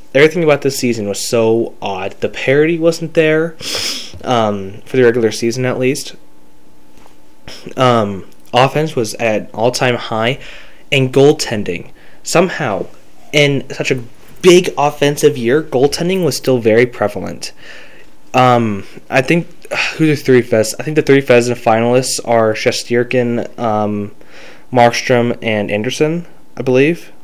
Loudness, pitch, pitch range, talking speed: -14 LUFS, 125 Hz, 115-145 Hz, 130 wpm